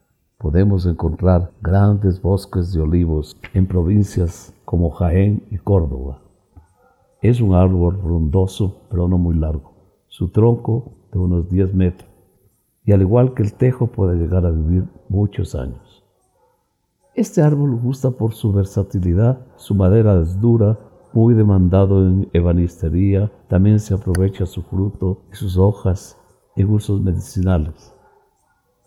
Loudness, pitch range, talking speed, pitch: -18 LUFS, 90-105 Hz, 130 wpm, 95 Hz